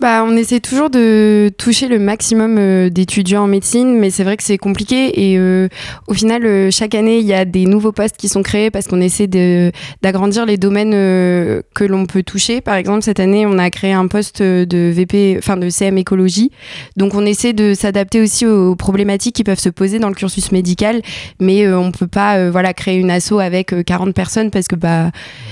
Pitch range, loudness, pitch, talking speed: 185-210 Hz, -13 LUFS, 195 Hz, 220 wpm